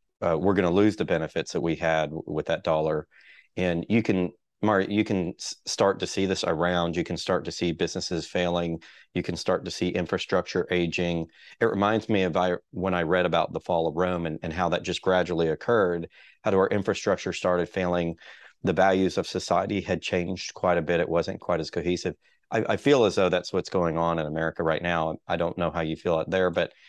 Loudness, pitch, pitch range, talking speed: -26 LUFS, 90 Hz, 85-95 Hz, 220 wpm